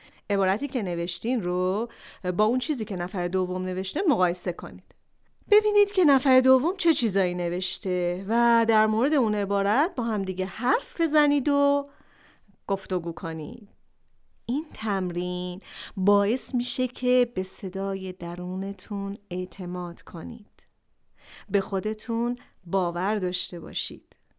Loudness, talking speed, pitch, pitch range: -26 LUFS, 115 wpm, 200 Hz, 180-245 Hz